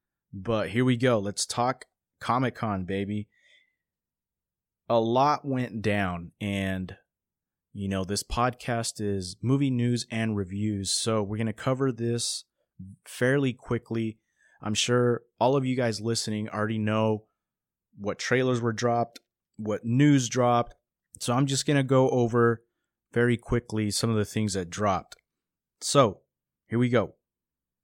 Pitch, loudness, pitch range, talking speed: 115 Hz, -27 LUFS, 105-125 Hz, 140 wpm